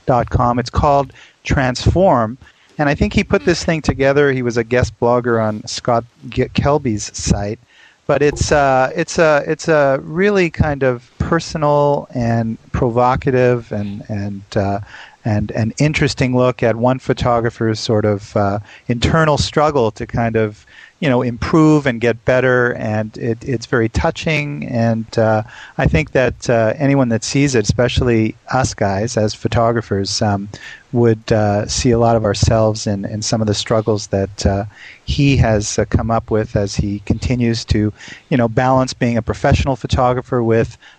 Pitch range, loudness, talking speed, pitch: 110-130 Hz, -16 LUFS, 170 wpm, 120 Hz